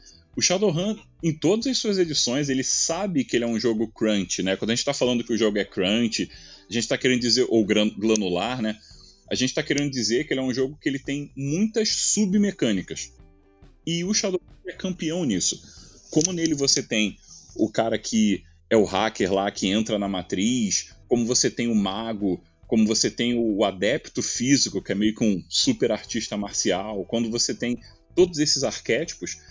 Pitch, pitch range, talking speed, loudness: 115 Hz, 105-150 Hz, 195 wpm, -23 LUFS